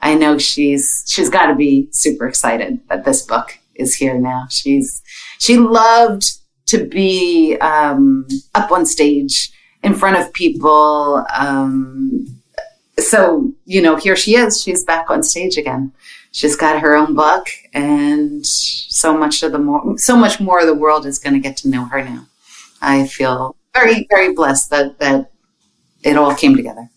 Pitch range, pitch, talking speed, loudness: 145-225 Hz, 155 Hz, 170 wpm, -13 LUFS